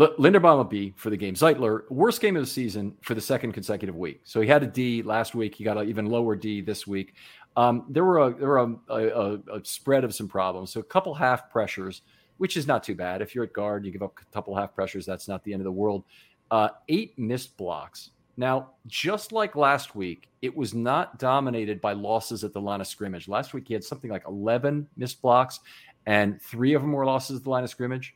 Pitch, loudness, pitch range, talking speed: 115 Hz, -26 LUFS, 105-130 Hz, 245 wpm